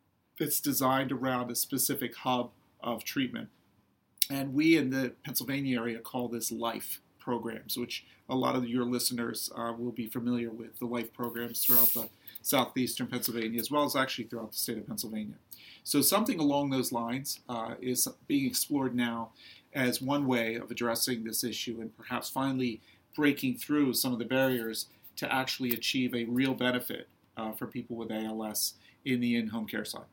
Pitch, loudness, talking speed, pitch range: 120 Hz, -31 LUFS, 175 wpm, 115-130 Hz